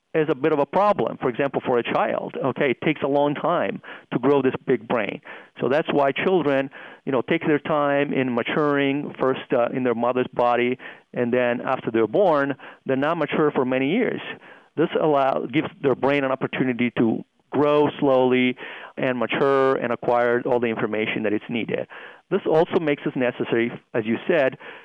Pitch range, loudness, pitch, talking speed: 120-145 Hz, -22 LUFS, 135 Hz, 190 wpm